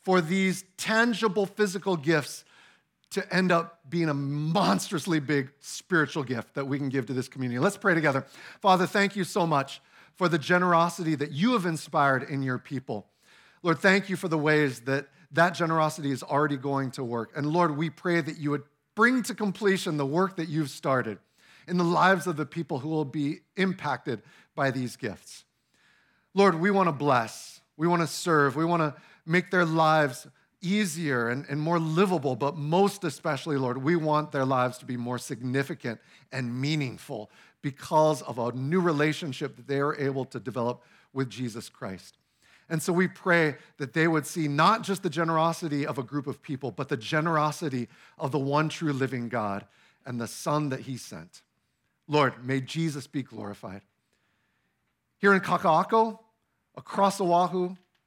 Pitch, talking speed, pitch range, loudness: 155 Hz, 175 wpm, 135-175 Hz, -27 LUFS